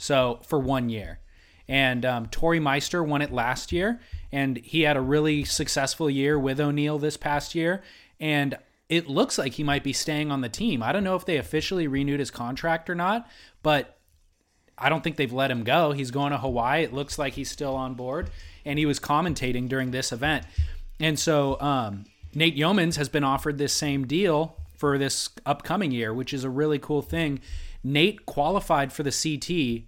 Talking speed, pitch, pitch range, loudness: 195 wpm, 140 Hz, 130-155 Hz, -26 LUFS